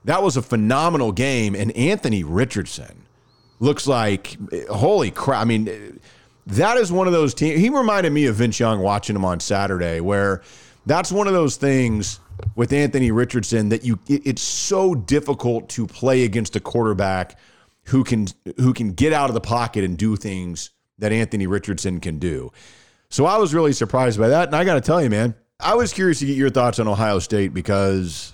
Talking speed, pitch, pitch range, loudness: 190 wpm, 115 Hz, 100-140 Hz, -20 LUFS